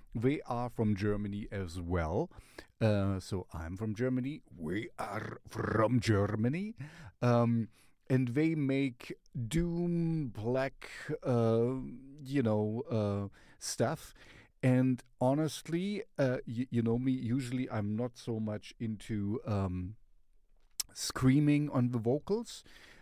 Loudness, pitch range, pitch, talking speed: -34 LUFS, 110-135 Hz, 125 Hz, 115 wpm